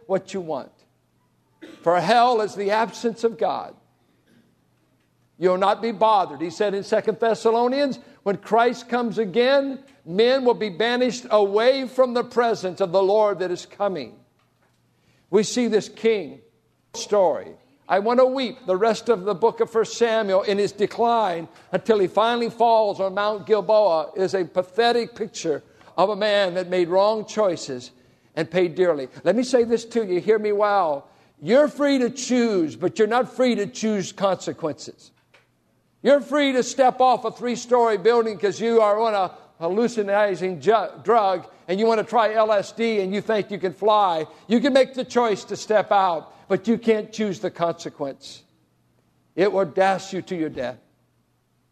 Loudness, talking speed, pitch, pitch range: -22 LUFS, 175 wpm, 215 Hz, 185-235 Hz